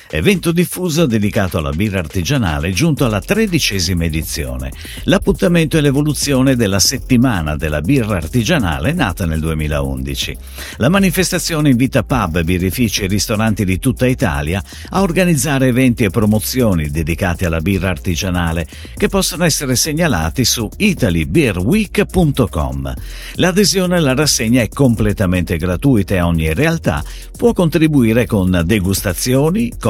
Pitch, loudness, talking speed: 110 Hz, -15 LUFS, 120 wpm